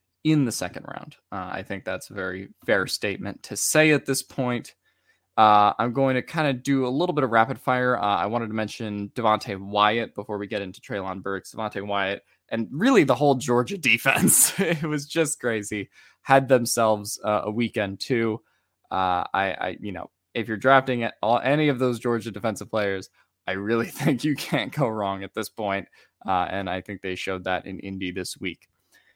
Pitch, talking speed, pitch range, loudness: 115 Hz, 200 wpm, 100-130 Hz, -24 LUFS